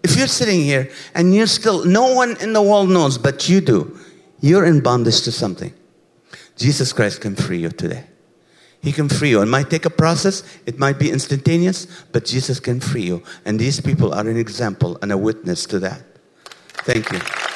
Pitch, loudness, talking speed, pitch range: 150 Hz, -17 LUFS, 200 wpm, 125-180 Hz